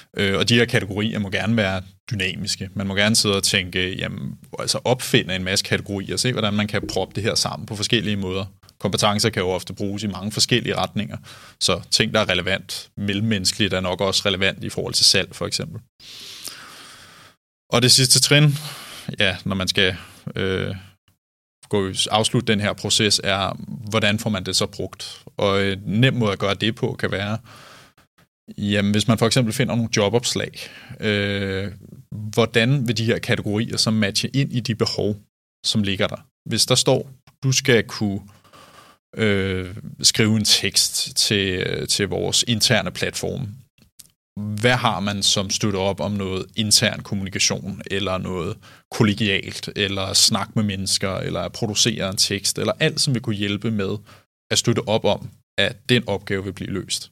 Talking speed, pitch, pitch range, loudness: 170 wpm, 105 Hz, 95-115 Hz, -20 LUFS